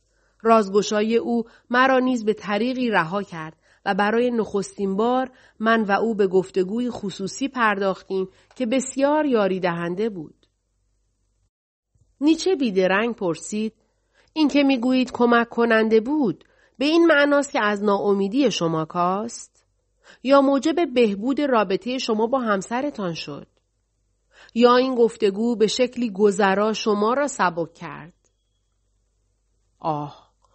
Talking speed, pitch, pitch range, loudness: 120 wpm, 210 Hz, 180-245 Hz, -21 LUFS